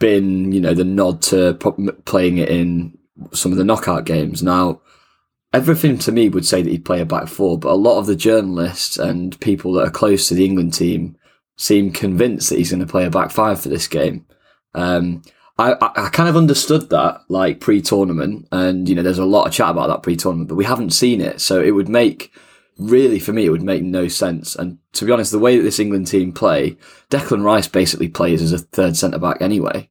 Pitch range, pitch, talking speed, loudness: 85-100 Hz, 90 Hz, 225 wpm, -16 LUFS